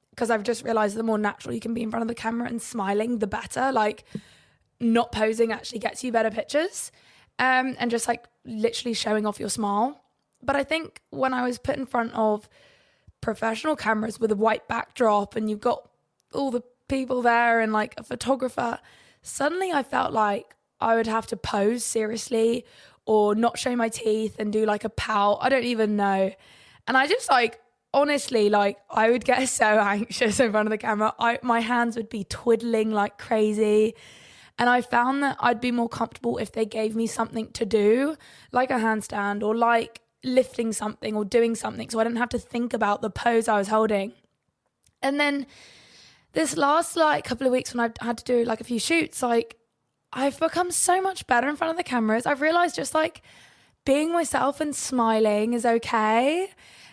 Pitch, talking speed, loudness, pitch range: 235 Hz, 195 wpm, -24 LUFS, 220-255 Hz